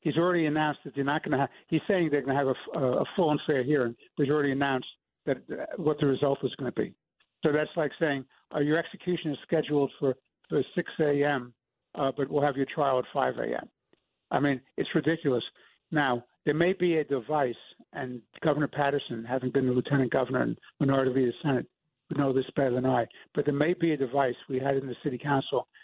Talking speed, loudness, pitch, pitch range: 225 wpm, -29 LUFS, 140 Hz, 130-155 Hz